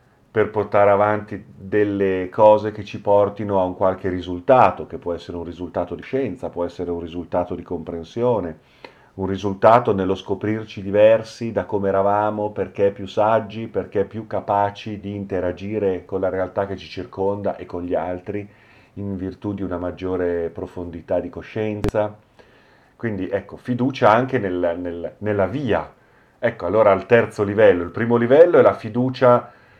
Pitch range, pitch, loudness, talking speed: 90-105 Hz, 100 Hz, -20 LUFS, 155 wpm